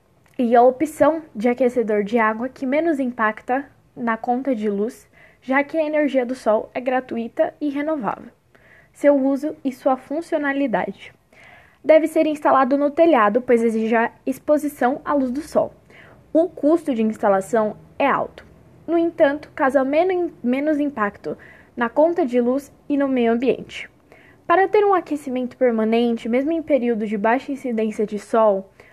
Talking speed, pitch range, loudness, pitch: 155 wpm, 235-300 Hz, -20 LUFS, 265 Hz